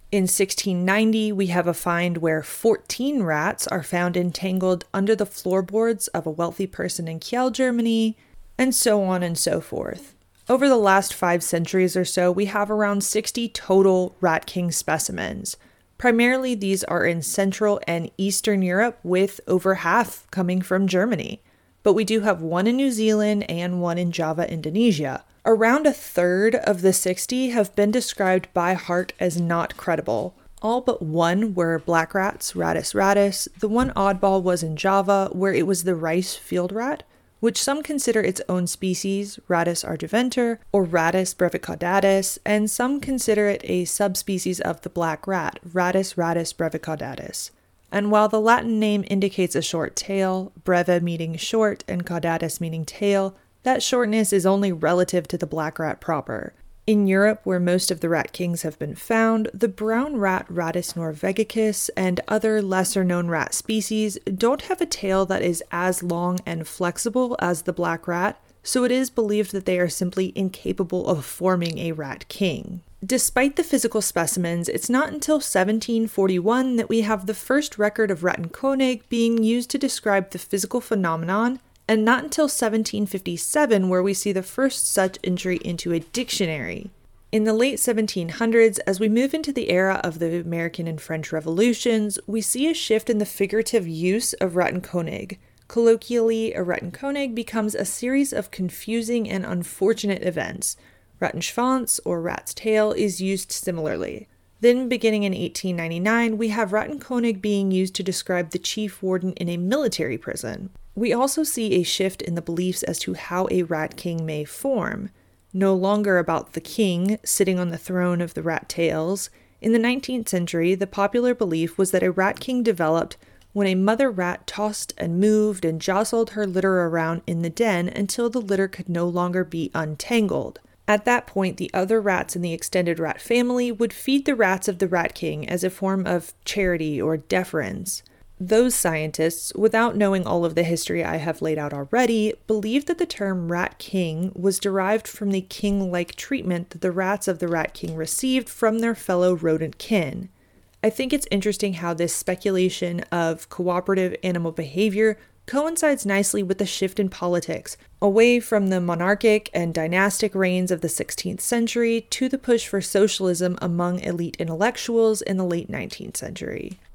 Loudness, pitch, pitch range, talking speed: -23 LUFS, 195 Hz, 175-220 Hz, 170 wpm